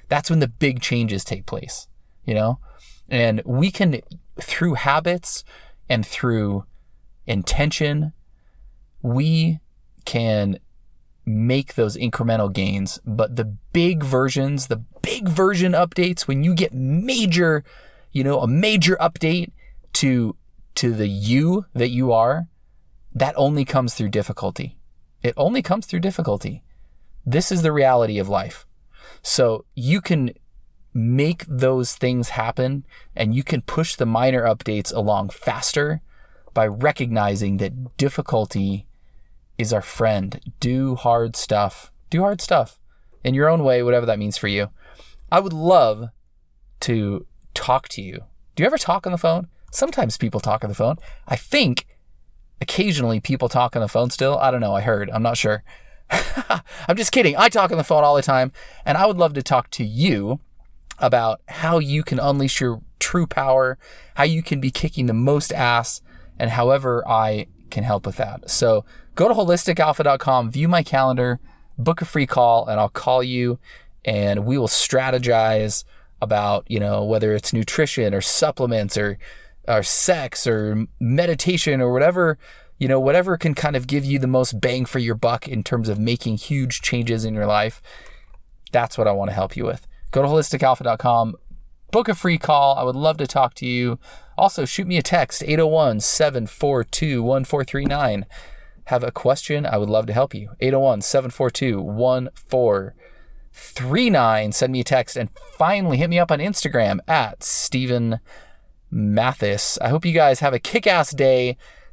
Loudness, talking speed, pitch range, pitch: -20 LUFS, 160 wpm, 110-155 Hz, 130 Hz